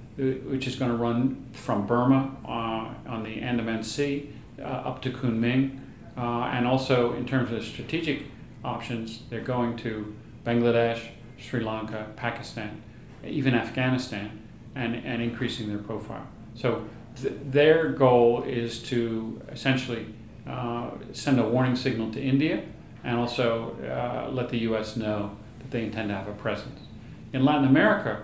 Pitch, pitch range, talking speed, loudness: 120 Hz, 115-130 Hz, 145 wpm, -27 LUFS